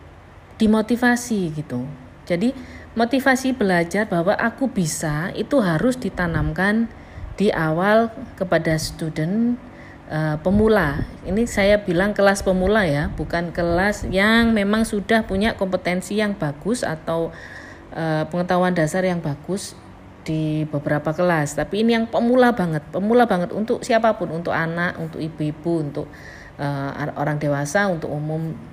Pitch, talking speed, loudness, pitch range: 180 Hz, 125 wpm, -21 LUFS, 155-215 Hz